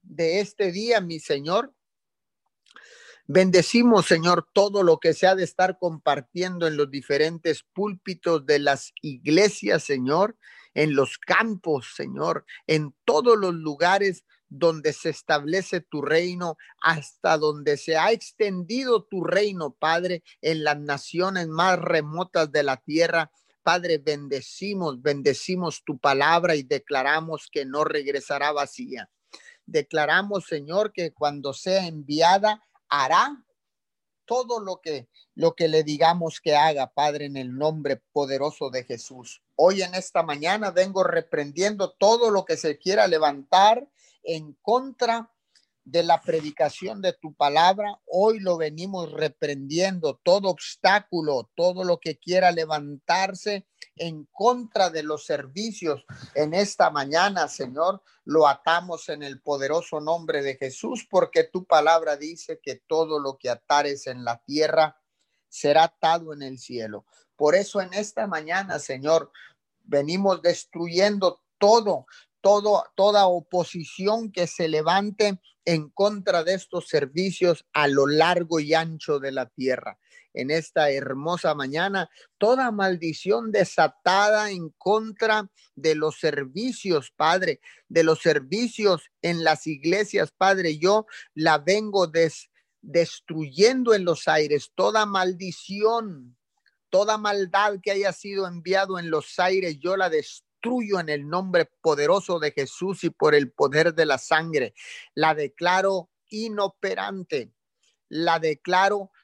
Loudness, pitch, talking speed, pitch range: -23 LUFS, 170 Hz, 130 wpm, 150-195 Hz